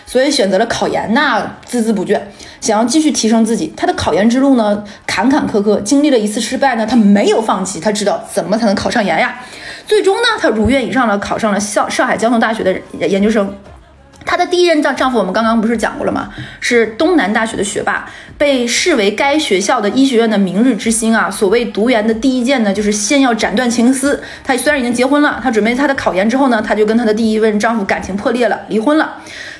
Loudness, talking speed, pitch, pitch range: -13 LUFS, 350 characters per minute, 230 Hz, 210-265 Hz